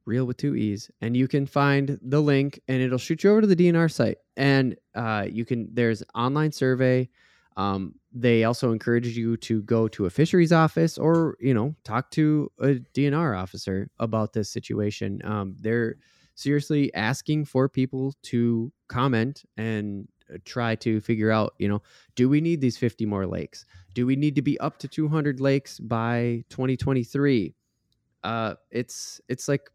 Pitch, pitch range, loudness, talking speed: 125 Hz, 110-140 Hz, -25 LUFS, 170 wpm